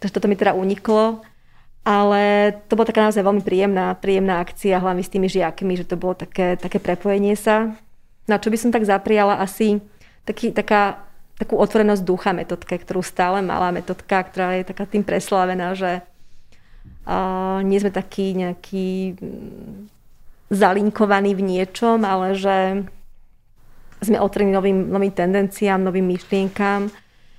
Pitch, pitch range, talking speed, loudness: 195 Hz, 185-205 Hz, 145 wpm, -20 LUFS